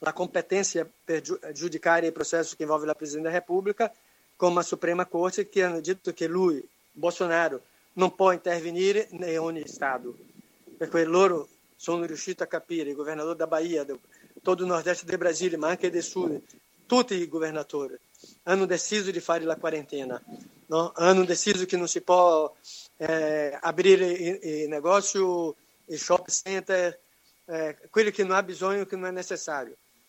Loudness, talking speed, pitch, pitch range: -27 LUFS, 145 wpm, 175 Hz, 160-185 Hz